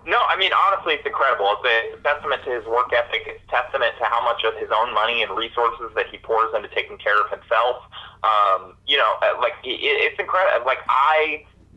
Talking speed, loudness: 210 wpm, -20 LUFS